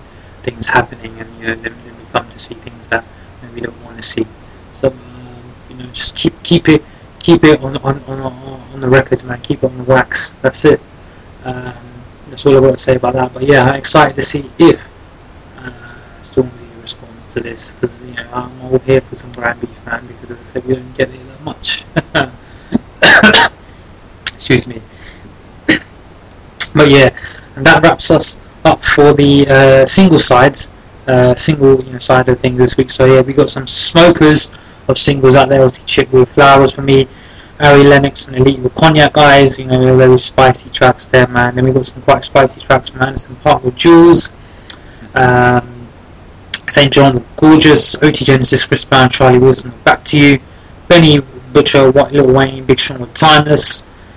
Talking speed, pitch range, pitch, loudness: 190 wpm, 115-135 Hz, 125 Hz, -9 LUFS